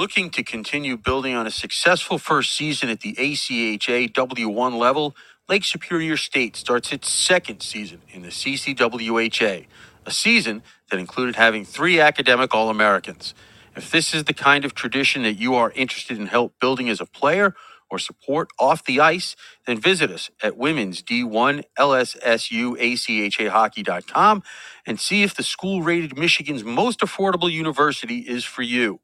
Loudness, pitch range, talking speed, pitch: -20 LUFS, 115-155 Hz, 160 wpm, 130 Hz